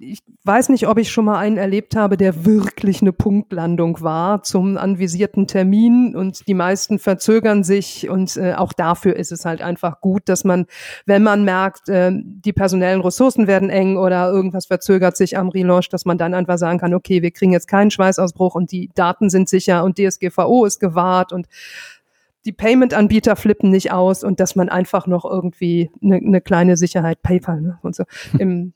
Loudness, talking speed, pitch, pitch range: -16 LUFS, 190 wpm, 190 Hz, 180-200 Hz